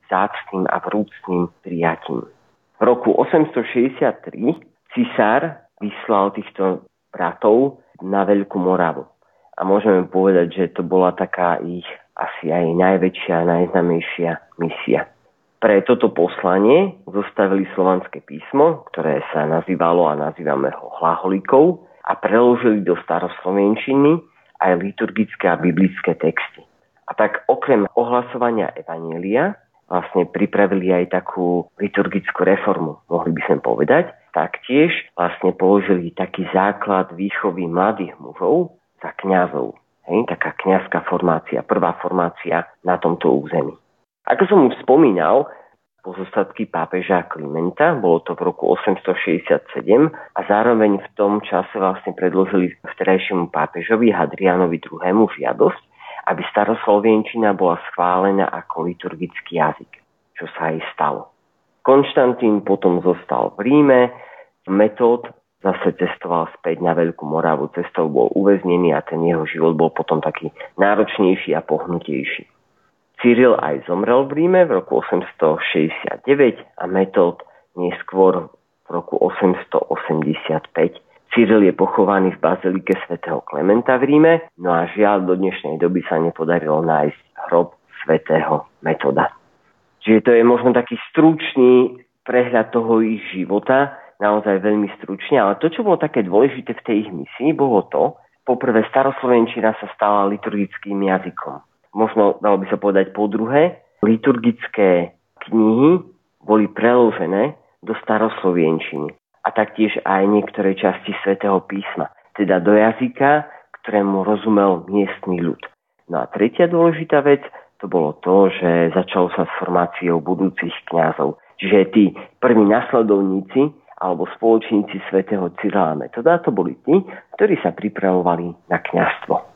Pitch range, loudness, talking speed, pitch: 90-110 Hz, -18 LUFS, 125 wpm, 100 Hz